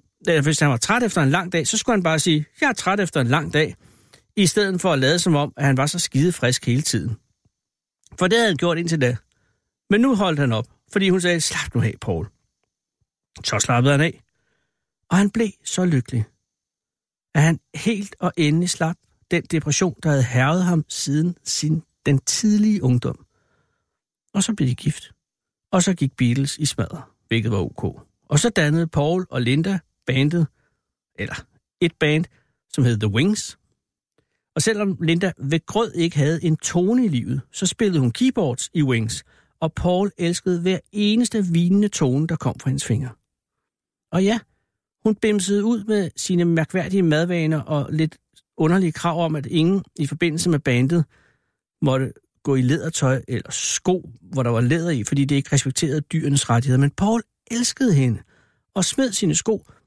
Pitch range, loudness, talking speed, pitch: 135-185 Hz, -21 LUFS, 180 wpm, 160 Hz